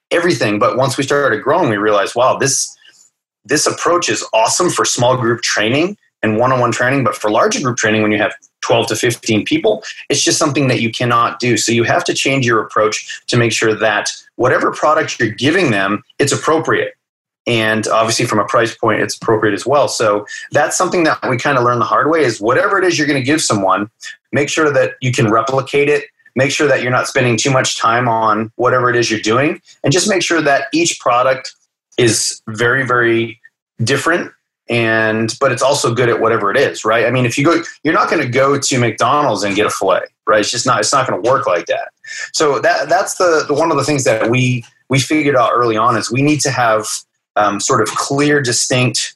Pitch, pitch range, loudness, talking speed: 125 Hz, 115-145 Hz, -14 LUFS, 225 wpm